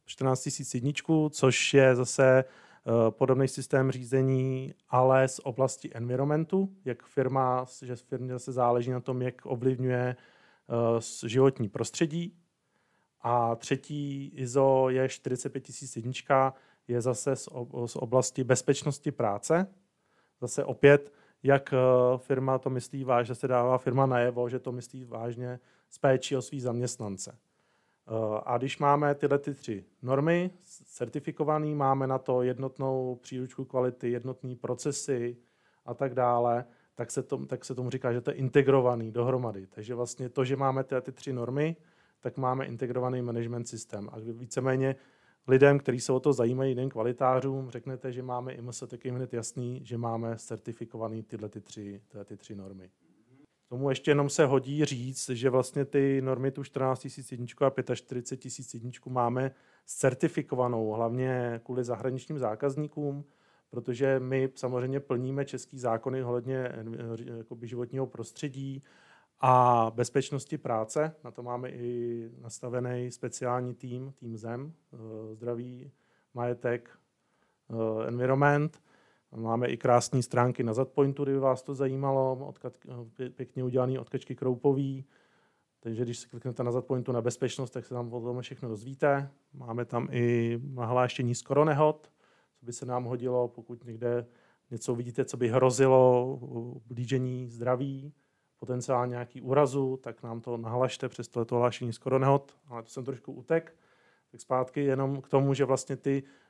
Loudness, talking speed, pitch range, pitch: -30 LUFS, 140 wpm, 120-135 Hz, 130 Hz